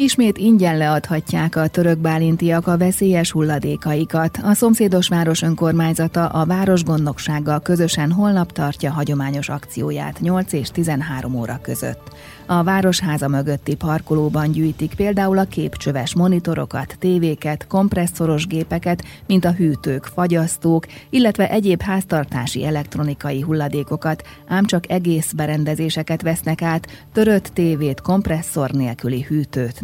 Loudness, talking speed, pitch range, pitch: -19 LUFS, 115 wpm, 150-180 Hz, 160 Hz